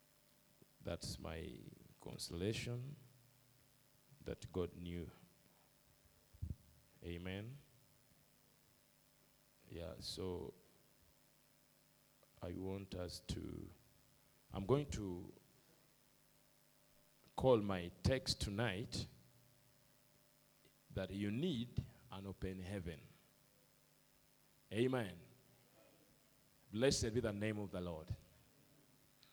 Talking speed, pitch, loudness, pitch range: 70 wpm, 105 Hz, -44 LUFS, 90-125 Hz